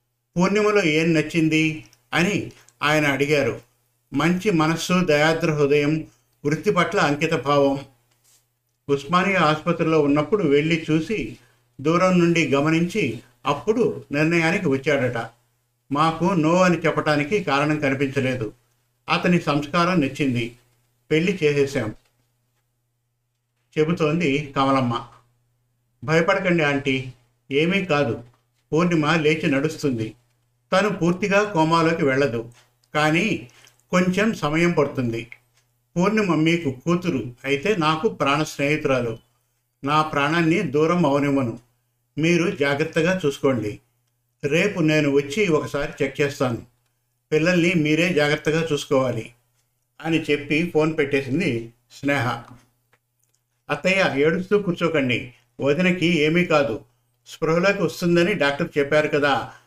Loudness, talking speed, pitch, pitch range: -21 LUFS, 95 wpm, 145 Hz, 120-160 Hz